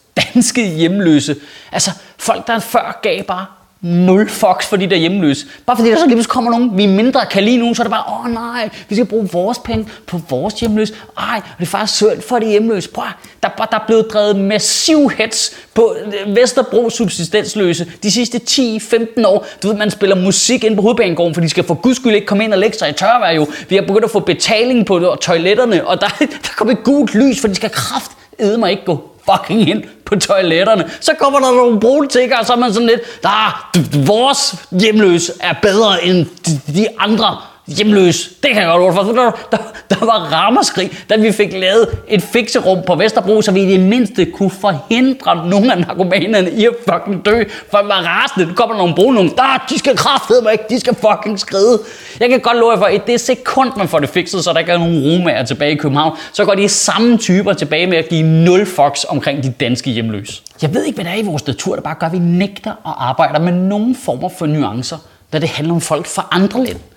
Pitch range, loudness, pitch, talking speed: 175-230 Hz, -13 LUFS, 205 Hz, 230 wpm